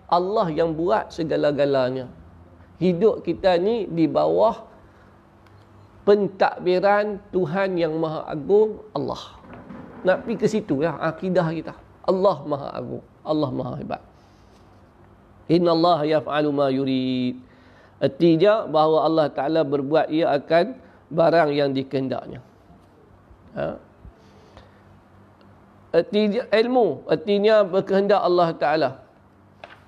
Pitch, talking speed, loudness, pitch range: 160 Hz, 100 wpm, -22 LUFS, 125-190 Hz